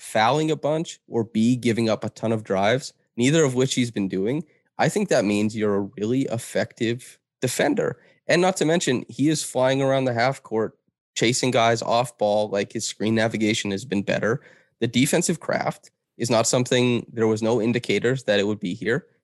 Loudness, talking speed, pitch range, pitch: -23 LUFS, 195 wpm, 110-130 Hz, 115 Hz